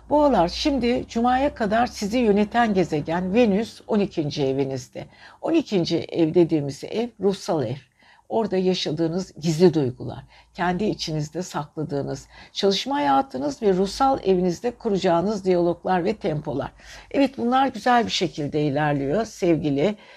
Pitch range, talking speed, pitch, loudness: 160-230 Hz, 115 wpm, 185 Hz, -23 LUFS